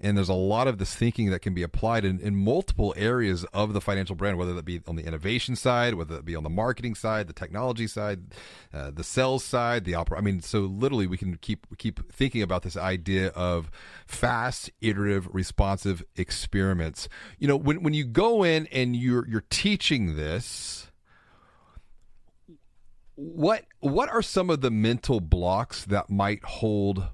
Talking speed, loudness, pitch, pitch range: 180 wpm, -27 LUFS, 100 Hz, 90-120 Hz